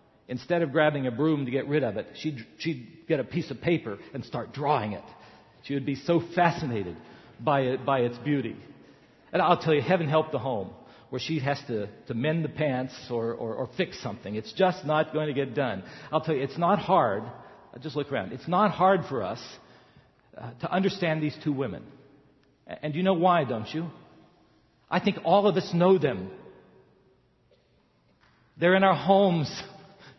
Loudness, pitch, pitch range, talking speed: -27 LUFS, 150 Hz, 130-170 Hz, 190 wpm